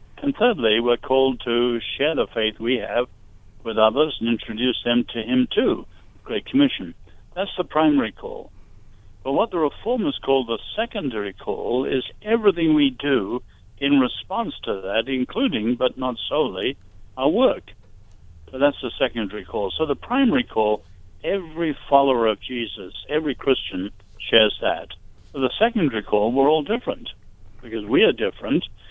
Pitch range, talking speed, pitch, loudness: 105-145 Hz, 155 wpm, 120 Hz, -22 LUFS